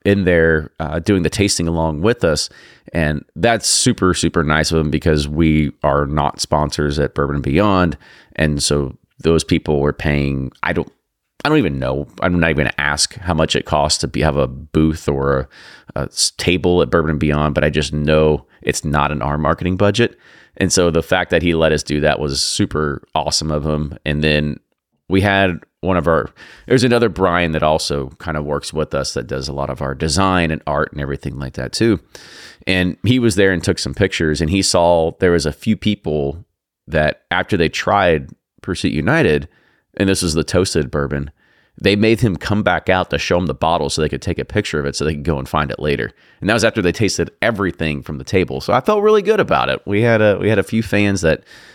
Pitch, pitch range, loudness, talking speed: 80 Hz, 75-95 Hz, -17 LUFS, 230 wpm